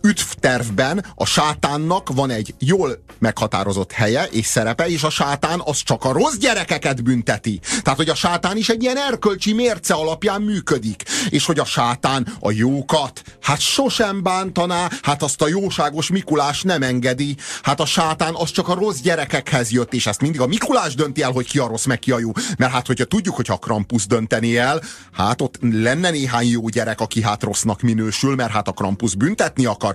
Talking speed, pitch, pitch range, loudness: 190 wpm, 140 Hz, 120-175 Hz, -19 LUFS